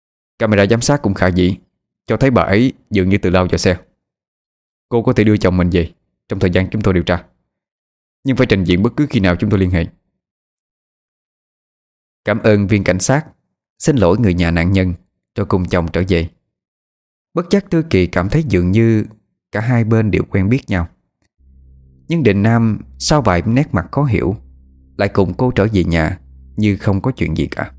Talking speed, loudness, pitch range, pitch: 205 wpm, -15 LUFS, 85-110 Hz, 95 Hz